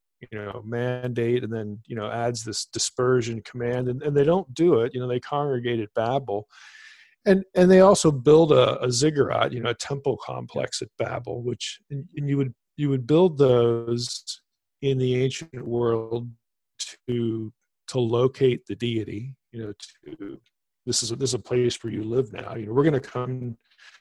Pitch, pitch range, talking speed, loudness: 125 Hz, 115-140 Hz, 185 wpm, -24 LUFS